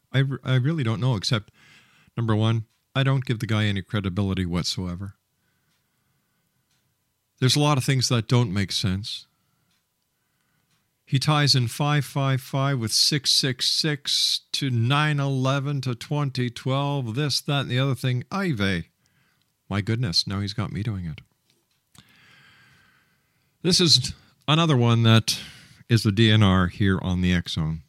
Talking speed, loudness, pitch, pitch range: 140 wpm, -23 LUFS, 125 Hz, 105-140 Hz